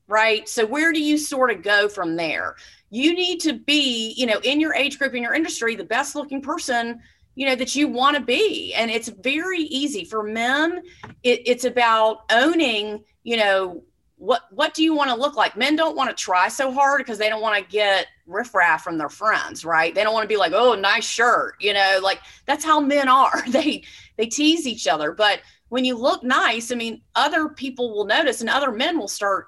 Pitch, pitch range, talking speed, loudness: 250 Hz, 215-295 Hz, 220 wpm, -20 LUFS